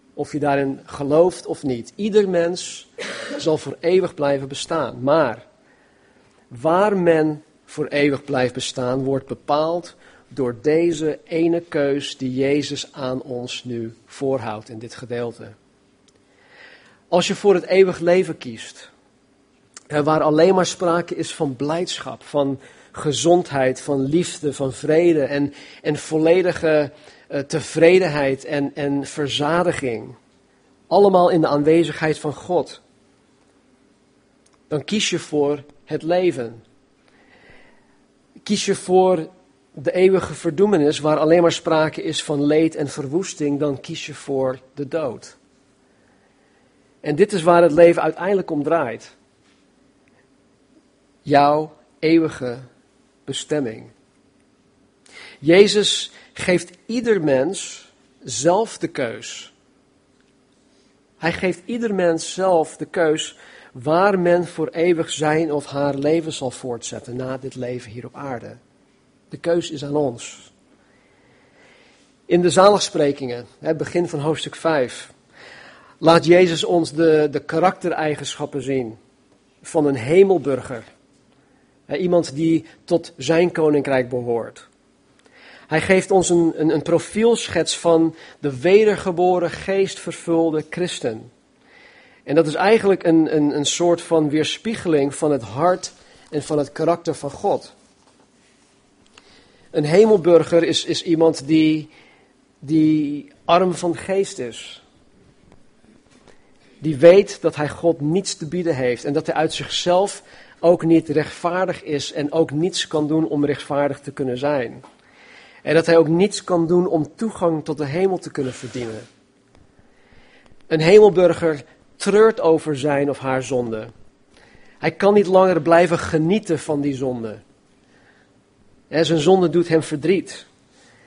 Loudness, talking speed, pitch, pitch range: -19 LUFS, 125 wpm, 155 Hz, 140-175 Hz